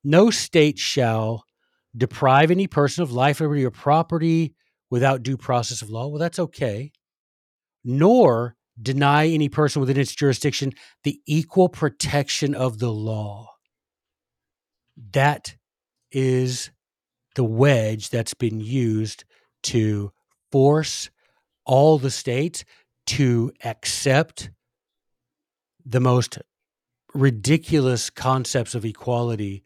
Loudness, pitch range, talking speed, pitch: -21 LUFS, 115-145 Hz, 105 wpm, 130 Hz